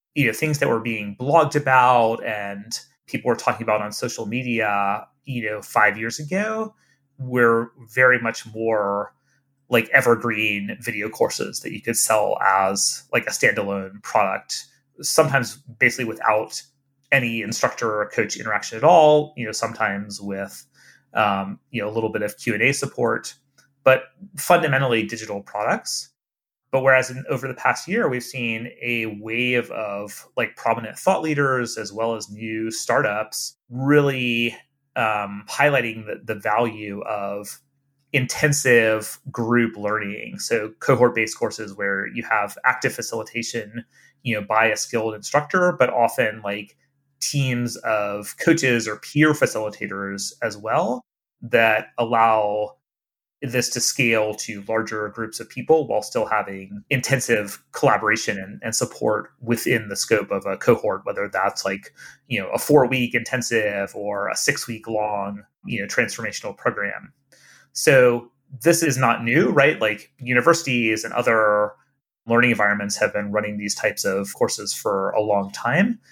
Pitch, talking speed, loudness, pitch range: 115 Hz, 145 wpm, -21 LUFS, 105-135 Hz